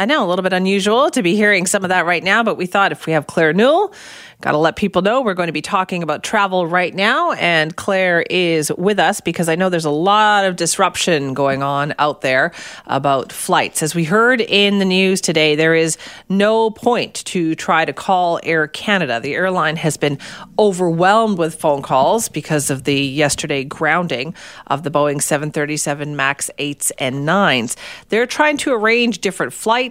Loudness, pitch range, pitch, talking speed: -16 LUFS, 155-200 Hz, 175 Hz, 200 wpm